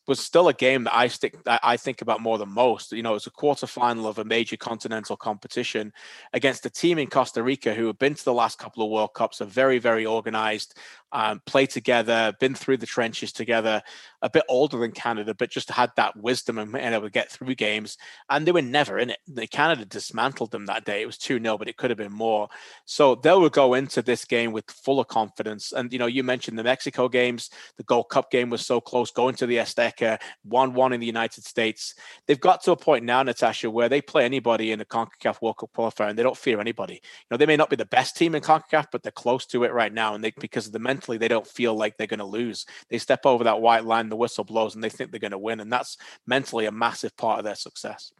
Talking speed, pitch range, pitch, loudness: 255 wpm, 110-130 Hz, 120 Hz, -24 LUFS